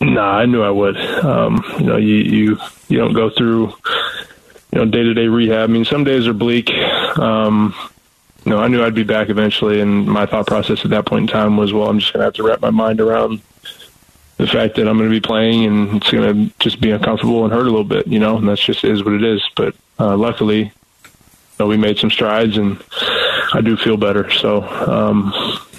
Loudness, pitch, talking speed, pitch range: -15 LUFS, 110 Hz, 230 wpm, 105-115 Hz